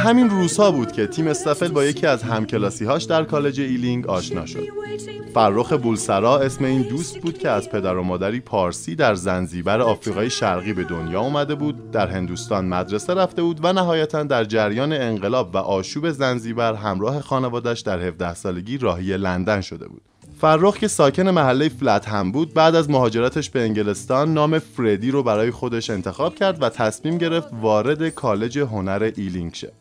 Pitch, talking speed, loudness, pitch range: 125 Hz, 170 wpm, -21 LUFS, 105-155 Hz